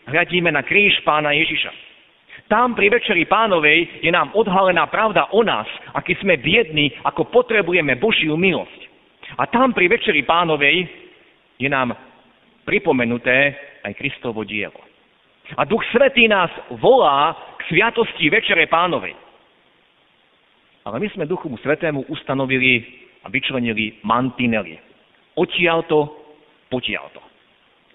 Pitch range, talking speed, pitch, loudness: 135-195 Hz, 115 wpm, 155 Hz, -17 LUFS